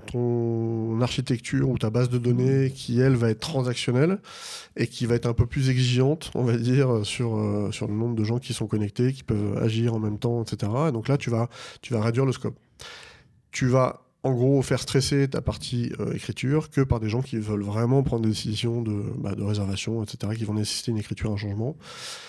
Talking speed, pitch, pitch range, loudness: 220 wpm, 120 Hz, 110-130 Hz, -25 LUFS